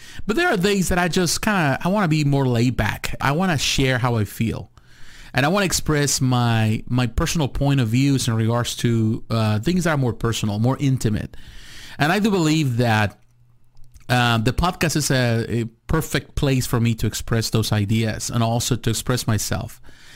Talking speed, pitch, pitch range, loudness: 200 wpm, 125 Hz, 115-145 Hz, -20 LUFS